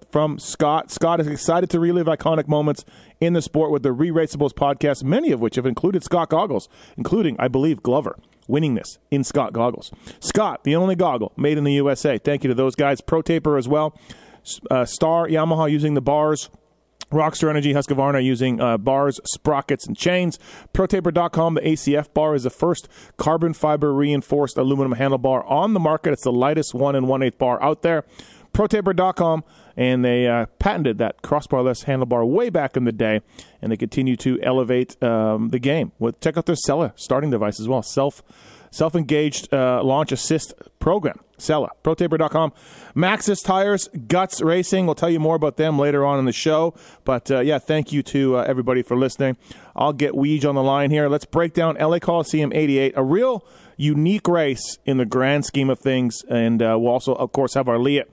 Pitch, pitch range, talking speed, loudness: 145 Hz, 130-160 Hz, 190 wpm, -20 LUFS